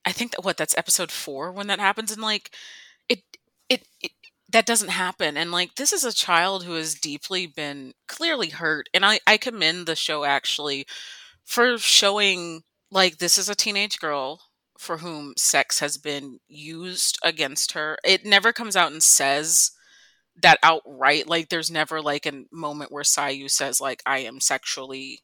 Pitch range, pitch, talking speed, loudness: 145-200 Hz, 165 Hz, 175 wpm, -21 LUFS